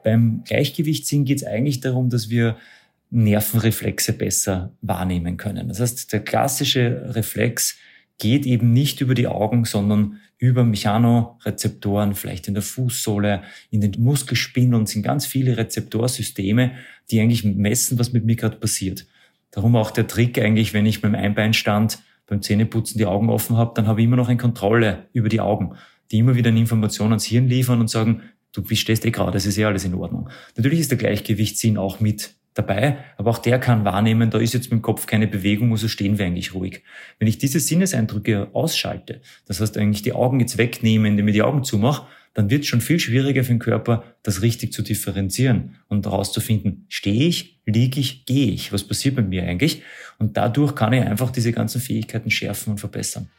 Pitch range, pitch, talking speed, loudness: 105-125 Hz, 115 Hz, 190 wpm, -20 LUFS